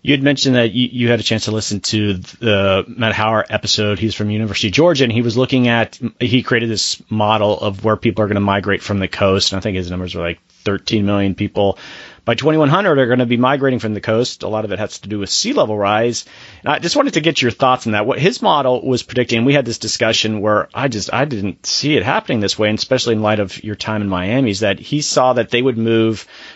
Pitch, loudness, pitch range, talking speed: 110 Hz, -16 LUFS, 105-125 Hz, 260 wpm